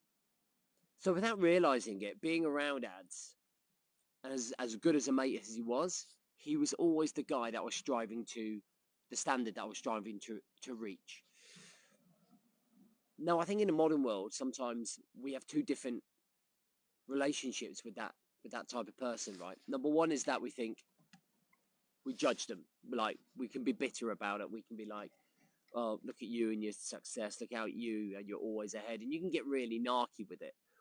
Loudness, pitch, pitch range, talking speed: -39 LUFS, 140 Hz, 115-190 Hz, 190 wpm